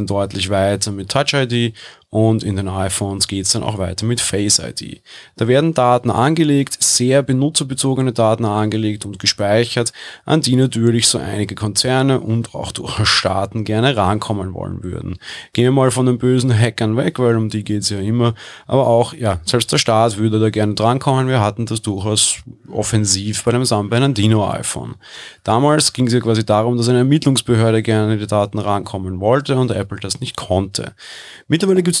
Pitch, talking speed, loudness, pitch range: 115 Hz, 180 wpm, -16 LUFS, 105-125 Hz